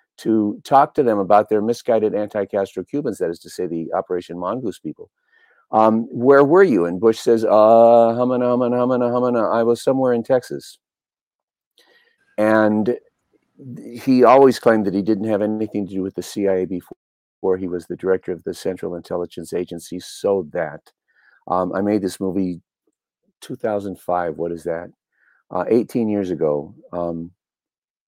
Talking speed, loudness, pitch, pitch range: 160 wpm, -19 LUFS, 105 Hz, 90-115 Hz